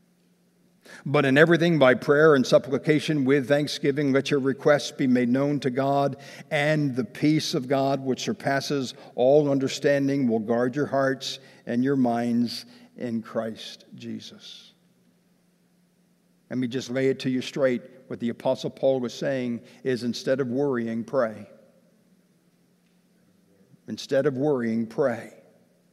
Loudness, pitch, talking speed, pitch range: -24 LUFS, 140 Hz, 135 wpm, 130-165 Hz